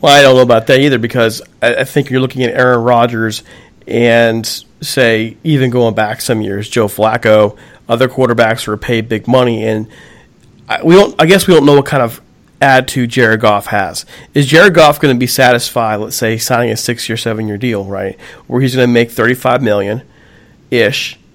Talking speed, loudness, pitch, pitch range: 195 wpm, -11 LUFS, 120 Hz, 110-130 Hz